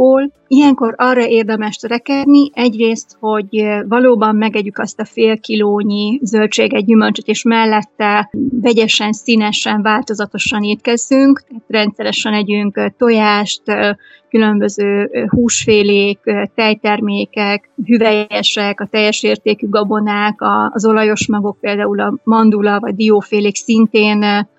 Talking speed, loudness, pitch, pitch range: 100 wpm, -13 LUFS, 215 Hz, 210-230 Hz